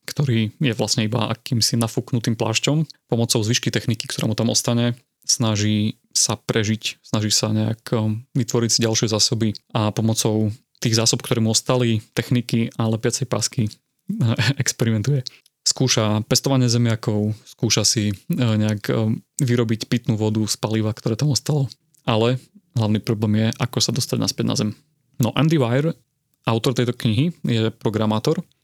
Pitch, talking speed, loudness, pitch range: 120 Hz, 145 wpm, -21 LUFS, 110-130 Hz